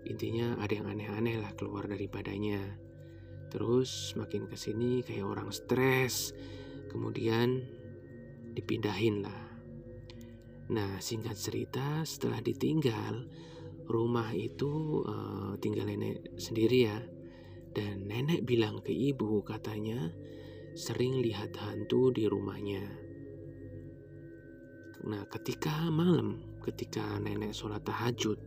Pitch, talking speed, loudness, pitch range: 110 Hz, 100 wpm, -34 LUFS, 100-120 Hz